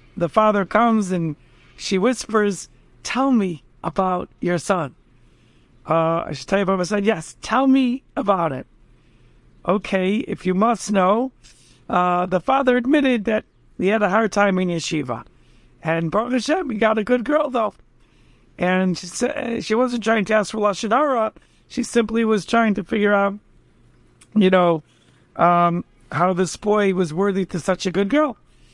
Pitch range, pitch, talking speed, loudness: 180-225 Hz, 200 Hz, 165 wpm, -20 LUFS